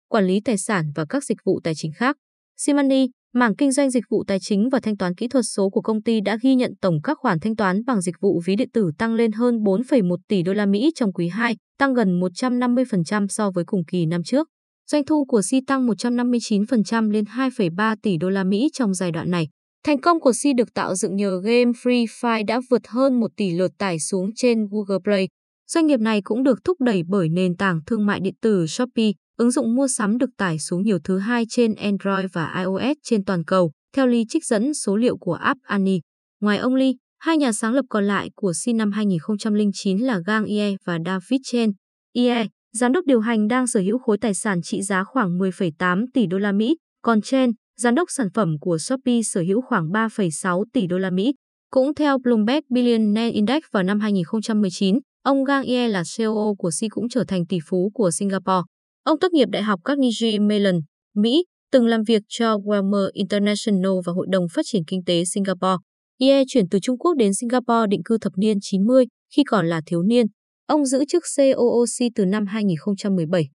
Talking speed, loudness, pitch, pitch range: 215 wpm, -21 LUFS, 215 Hz, 195-245 Hz